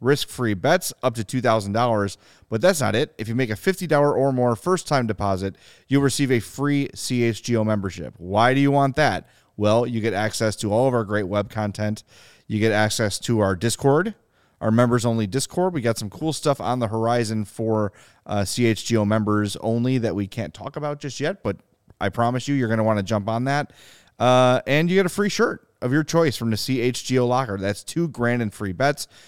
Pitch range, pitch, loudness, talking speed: 105-135 Hz, 120 Hz, -22 LUFS, 215 wpm